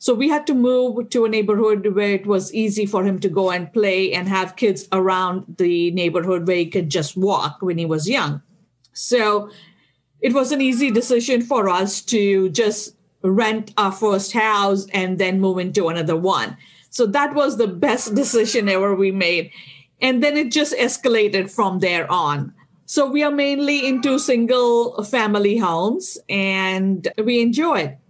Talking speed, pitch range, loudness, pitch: 175 wpm, 185-245 Hz, -19 LUFS, 205 Hz